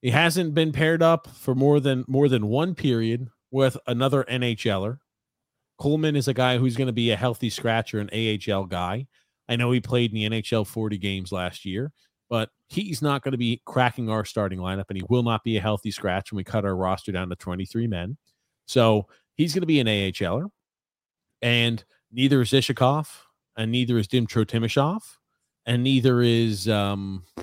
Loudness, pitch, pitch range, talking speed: -24 LUFS, 120 Hz, 105-135 Hz, 190 wpm